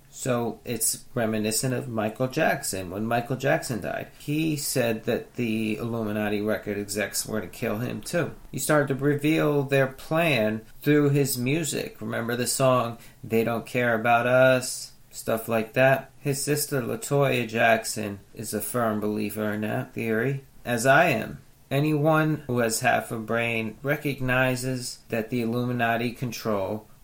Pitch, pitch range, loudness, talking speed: 120 Hz, 110-135 Hz, -25 LUFS, 150 wpm